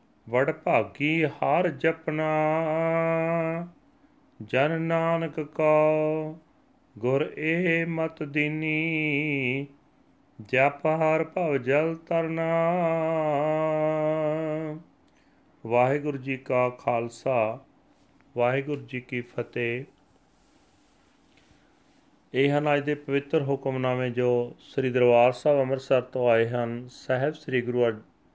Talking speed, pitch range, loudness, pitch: 85 wpm, 130-160 Hz, -26 LUFS, 150 Hz